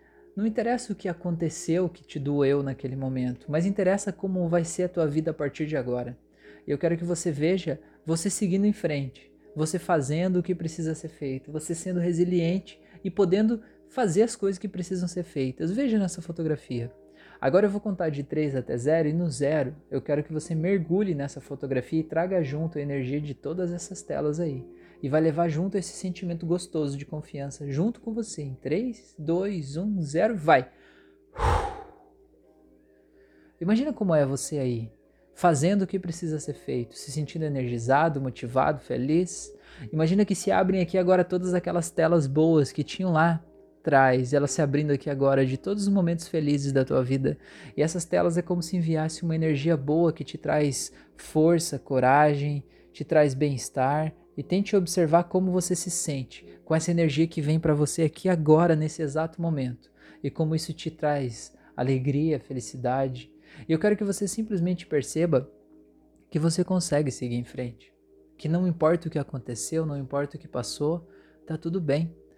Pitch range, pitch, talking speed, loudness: 140-175 Hz, 155 Hz, 175 wpm, -27 LUFS